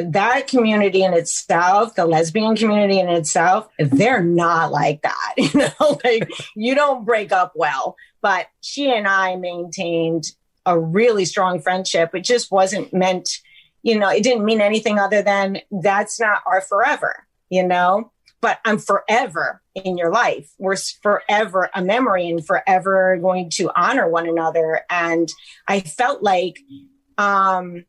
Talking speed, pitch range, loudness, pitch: 150 wpm, 175-220 Hz, -18 LUFS, 190 Hz